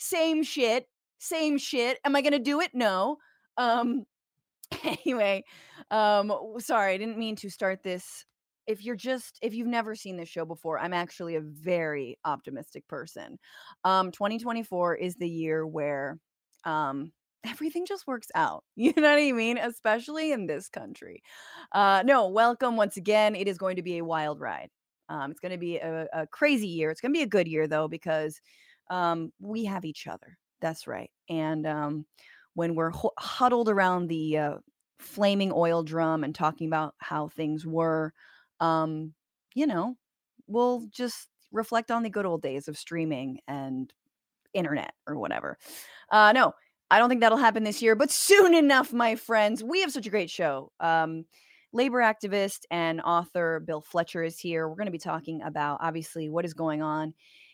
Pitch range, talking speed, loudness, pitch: 160-235 Hz, 175 wpm, -27 LUFS, 190 Hz